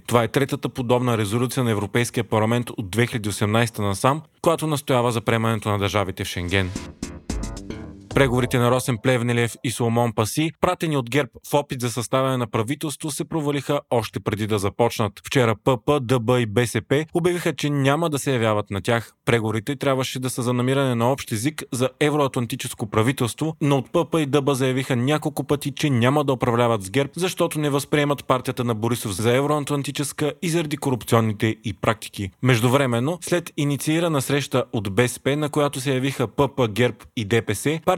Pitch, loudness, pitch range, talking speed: 130 Hz, -22 LUFS, 115-145 Hz, 170 wpm